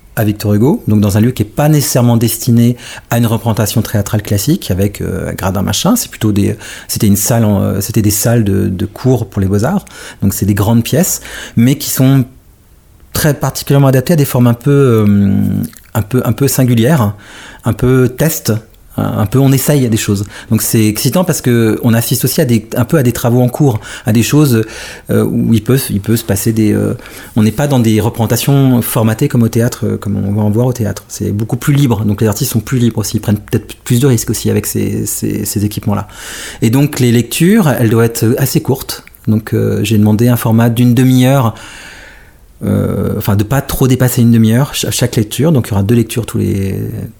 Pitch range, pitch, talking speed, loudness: 105-130 Hz, 115 Hz, 225 wpm, -12 LUFS